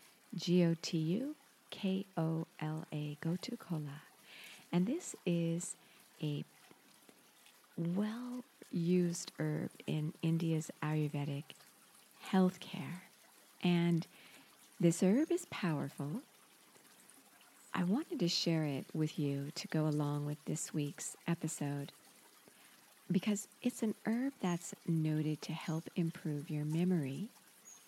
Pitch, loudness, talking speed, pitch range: 170 Hz, -38 LUFS, 110 wpm, 155-190 Hz